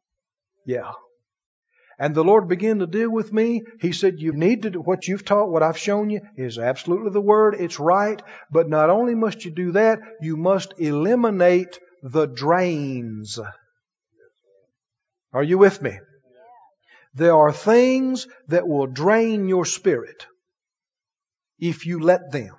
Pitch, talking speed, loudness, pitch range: 180 Hz, 150 wpm, -20 LUFS, 160-220 Hz